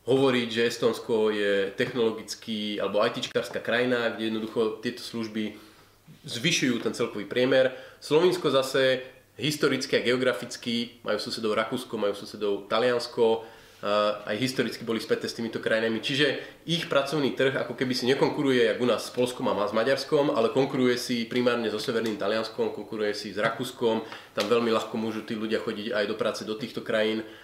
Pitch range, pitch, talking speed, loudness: 110-125 Hz, 115 Hz, 165 wpm, -27 LUFS